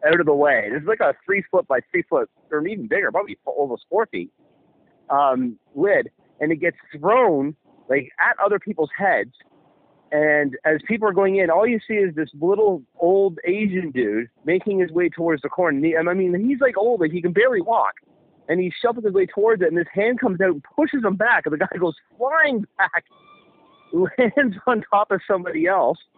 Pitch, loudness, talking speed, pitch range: 185 Hz, -20 LUFS, 210 wpm, 160-215 Hz